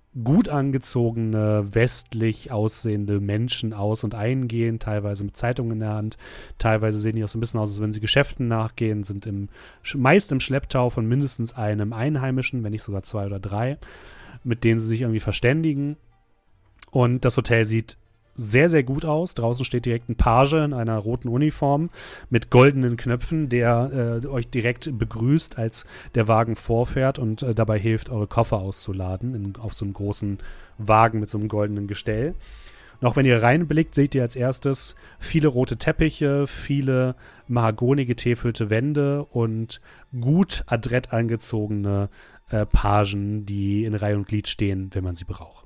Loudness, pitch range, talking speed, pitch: -23 LUFS, 105-130 Hz, 165 wpm, 115 Hz